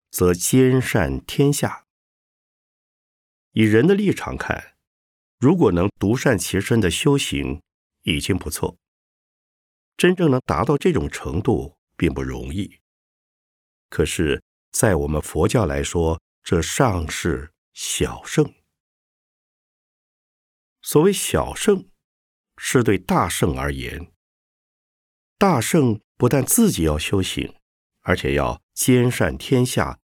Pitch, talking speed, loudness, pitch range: 100 Hz, 155 characters per minute, -20 LUFS, 80-130 Hz